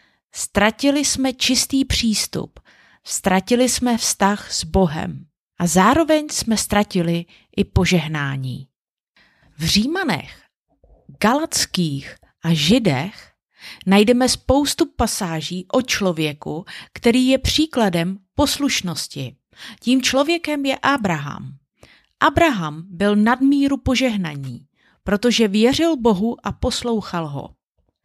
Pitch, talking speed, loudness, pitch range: 210 Hz, 90 wpm, -19 LUFS, 170-260 Hz